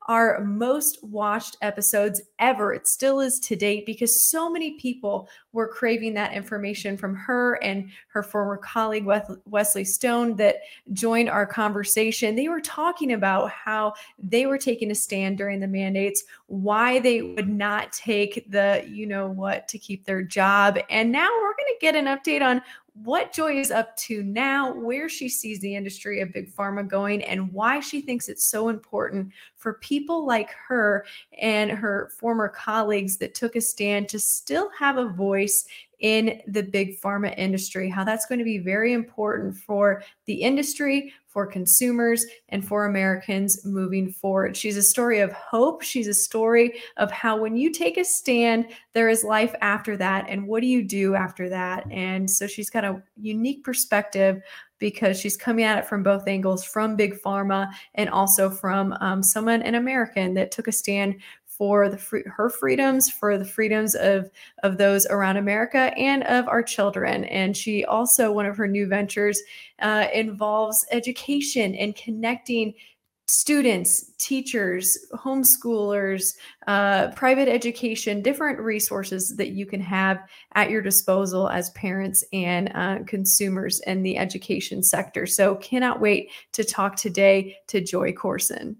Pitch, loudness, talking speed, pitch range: 210 Hz, -23 LUFS, 165 wpm, 200-235 Hz